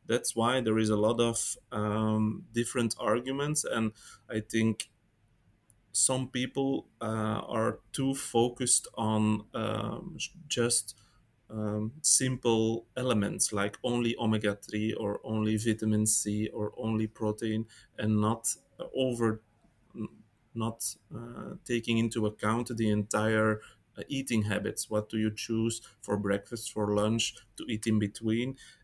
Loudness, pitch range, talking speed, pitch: -30 LUFS, 105-120 Hz, 125 wpm, 110 Hz